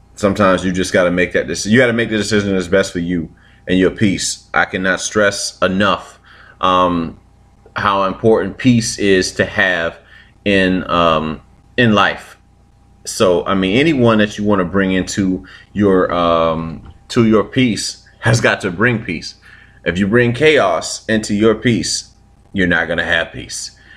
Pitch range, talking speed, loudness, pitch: 90-110 Hz, 175 wpm, -15 LUFS, 95 Hz